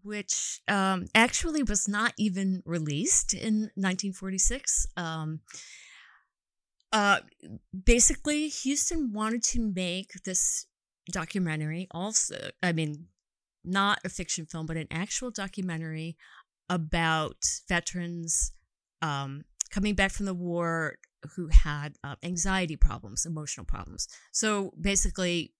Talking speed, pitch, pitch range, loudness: 110 wpm, 185 Hz, 165-205 Hz, -29 LUFS